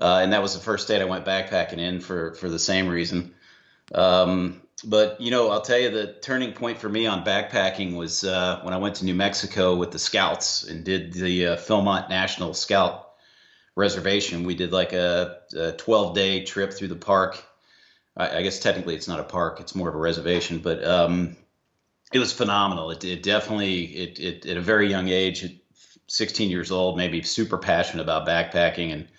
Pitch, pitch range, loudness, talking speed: 90 Hz, 85-100 Hz, -24 LUFS, 195 wpm